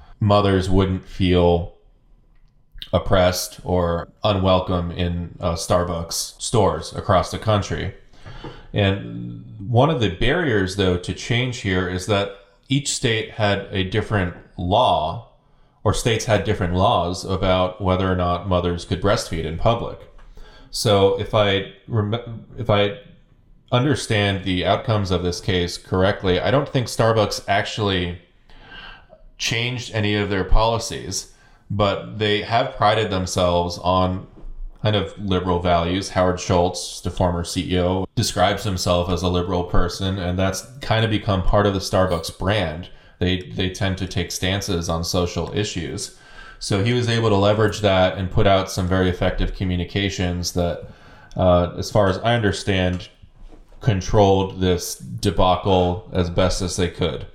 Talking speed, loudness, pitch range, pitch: 140 wpm, -21 LUFS, 90-105 Hz, 95 Hz